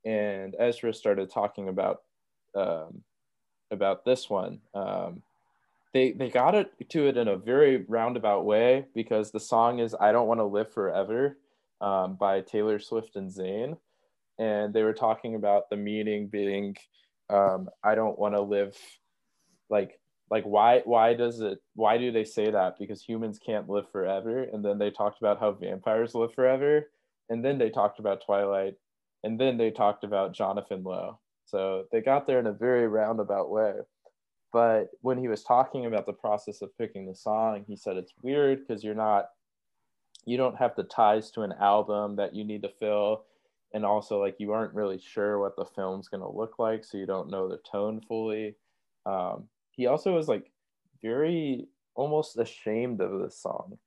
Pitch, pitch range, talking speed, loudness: 105 Hz, 100-115 Hz, 180 wpm, -28 LUFS